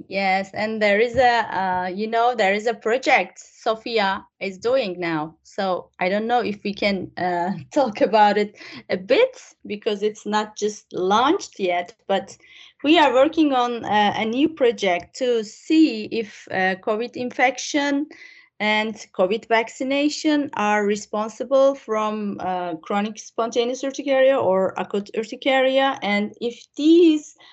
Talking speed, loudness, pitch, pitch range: 145 wpm, -21 LUFS, 220 Hz, 205-265 Hz